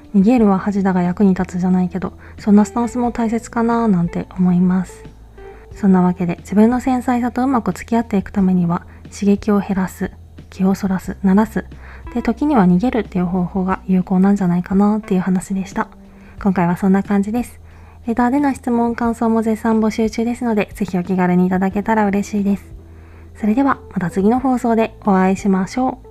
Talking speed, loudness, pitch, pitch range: 405 characters per minute, -17 LUFS, 200 Hz, 185-230 Hz